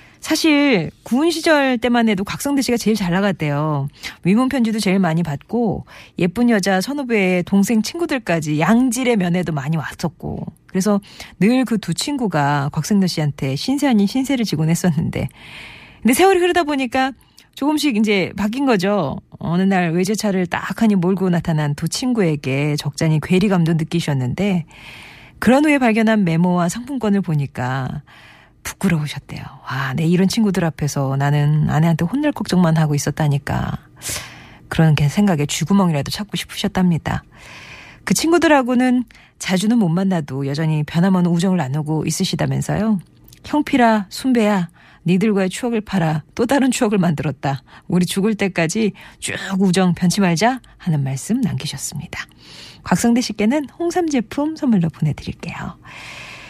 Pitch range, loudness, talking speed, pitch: 160-230 Hz, -18 LUFS, 330 characters per minute, 190 Hz